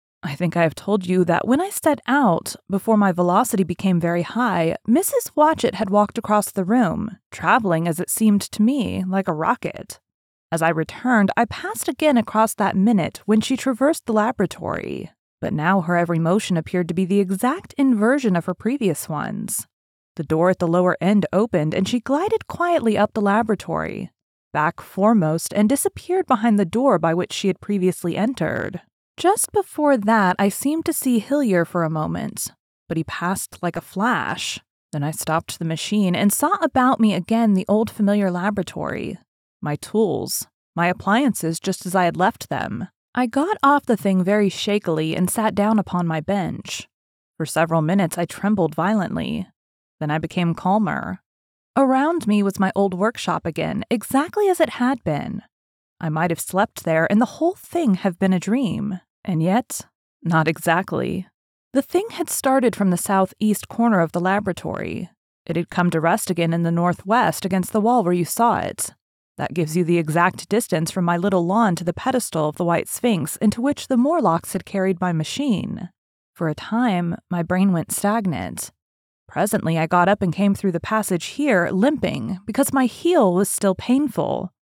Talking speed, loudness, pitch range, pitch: 185 wpm, -21 LUFS, 175-235 Hz, 200 Hz